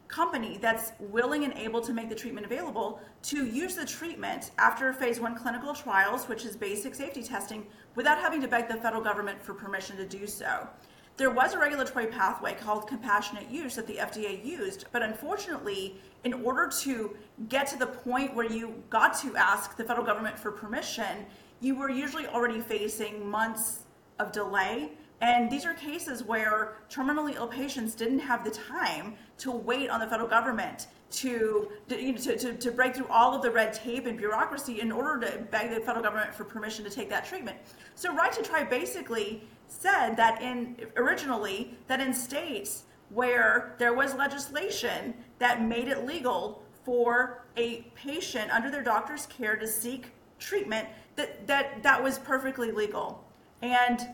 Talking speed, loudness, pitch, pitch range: 175 wpm, -30 LUFS, 240 Hz, 220-265 Hz